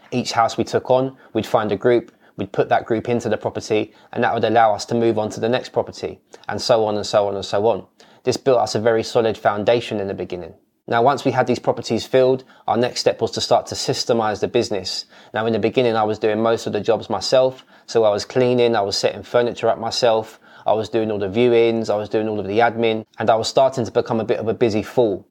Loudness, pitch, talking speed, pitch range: -19 LUFS, 115 Hz, 265 wpm, 110-120 Hz